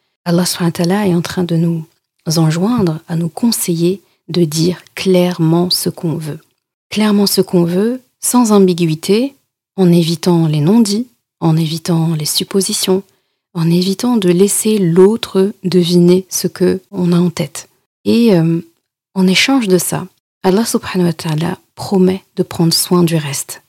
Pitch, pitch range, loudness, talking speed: 180 Hz, 170-195 Hz, -14 LUFS, 135 wpm